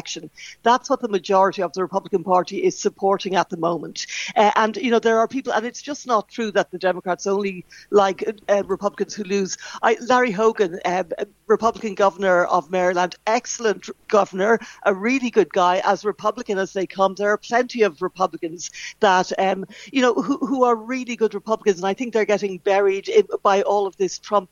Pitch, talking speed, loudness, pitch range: 205 Hz, 200 wpm, -21 LUFS, 190-225 Hz